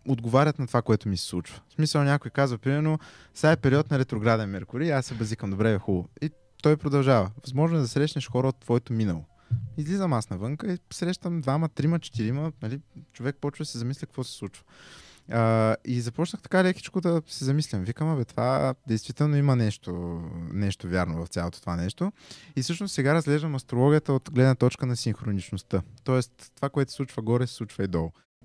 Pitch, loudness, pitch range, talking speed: 130 Hz, -27 LUFS, 110-150 Hz, 195 wpm